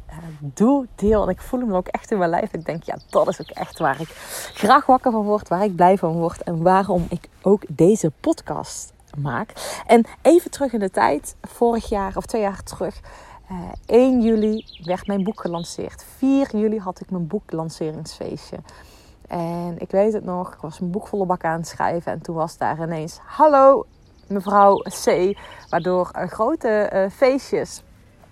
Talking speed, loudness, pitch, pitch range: 190 wpm, -20 LUFS, 195 Hz, 170-220 Hz